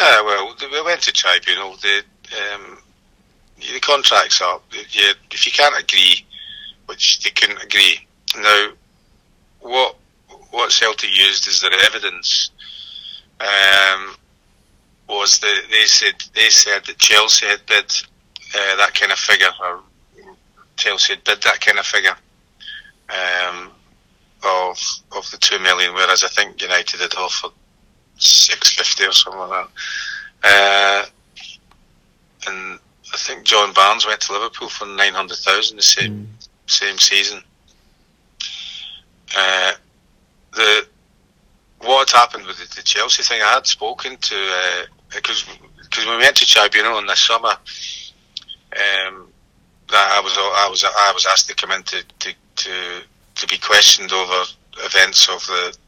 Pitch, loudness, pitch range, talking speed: 100 Hz, -14 LUFS, 95-120 Hz, 145 wpm